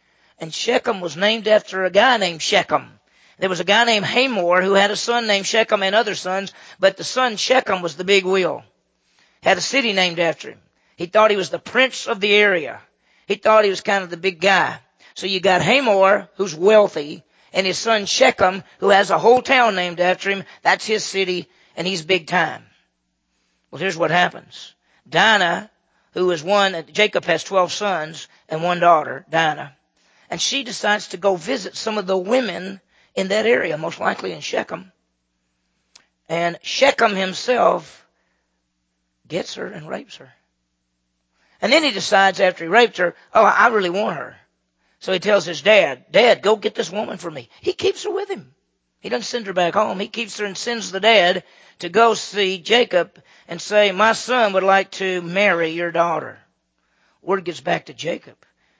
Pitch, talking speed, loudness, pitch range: 195 Hz, 190 wpm, -18 LUFS, 175-215 Hz